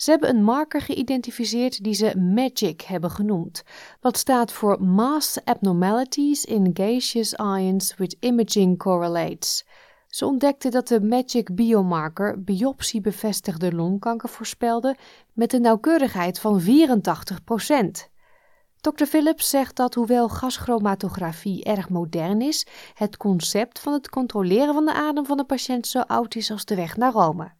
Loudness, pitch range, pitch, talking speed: -22 LUFS, 195-255 Hz, 225 Hz, 135 wpm